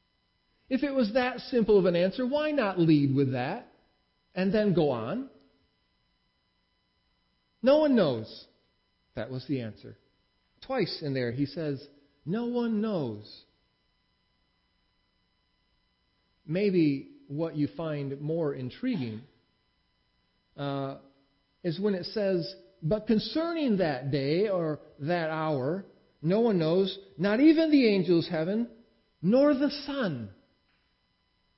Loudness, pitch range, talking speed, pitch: -28 LUFS, 135-215 Hz, 115 wpm, 165 Hz